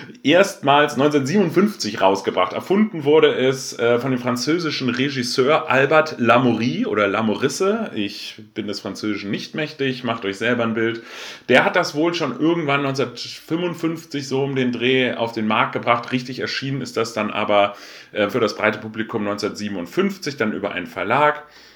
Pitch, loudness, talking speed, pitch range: 125 Hz, -20 LUFS, 150 wpm, 110-150 Hz